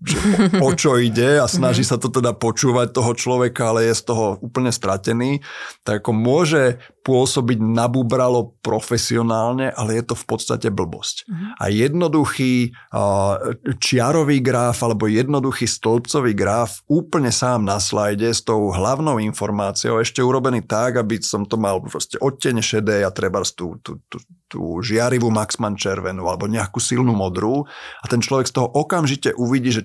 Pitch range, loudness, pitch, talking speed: 110-130 Hz, -19 LUFS, 120 Hz, 150 wpm